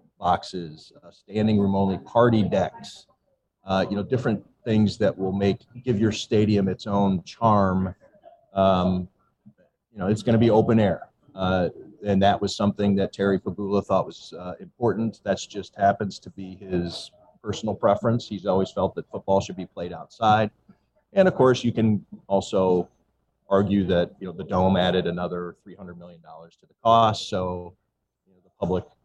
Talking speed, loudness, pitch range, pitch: 175 wpm, -24 LUFS, 95-110 Hz, 100 Hz